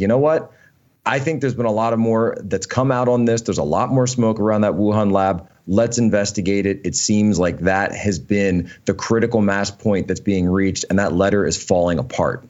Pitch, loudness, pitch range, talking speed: 105 Hz, -19 LUFS, 100-115 Hz, 225 wpm